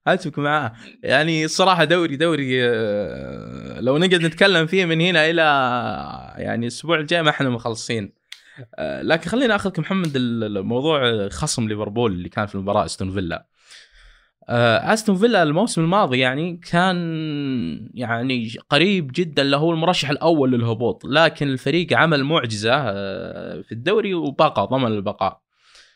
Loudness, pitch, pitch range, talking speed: -19 LUFS, 150 Hz, 120-170 Hz, 125 wpm